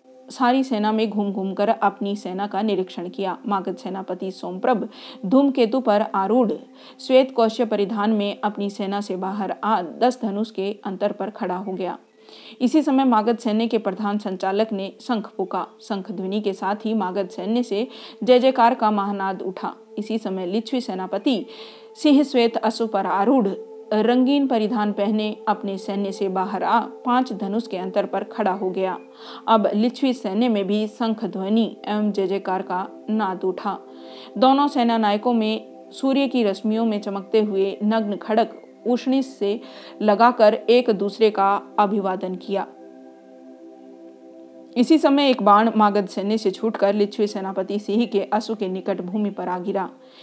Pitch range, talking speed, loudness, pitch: 195-230 Hz, 155 wpm, -22 LUFS, 210 Hz